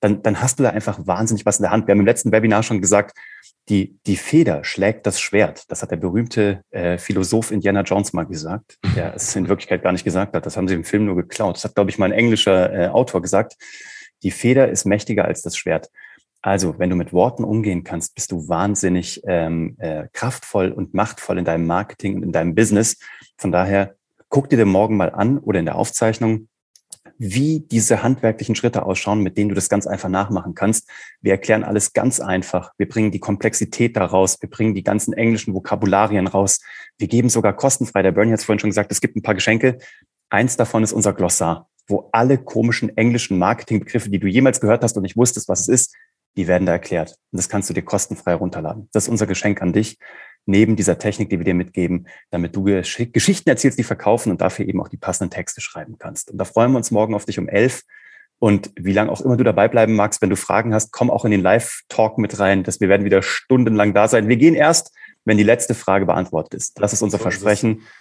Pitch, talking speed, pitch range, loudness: 105 Hz, 230 wpm, 95-115 Hz, -18 LUFS